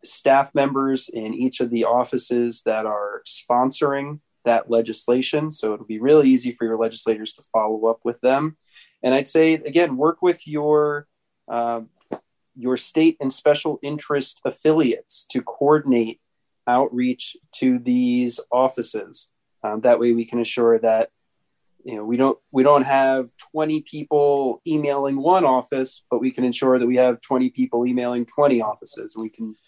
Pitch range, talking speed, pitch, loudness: 120-145 Hz, 160 wpm, 130 Hz, -21 LUFS